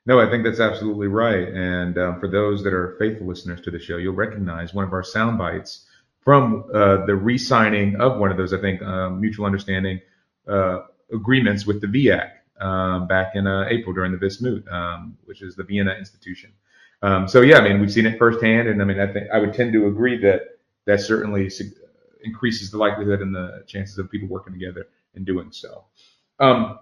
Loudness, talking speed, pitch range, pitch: -20 LUFS, 205 wpm, 95-110 Hz, 100 Hz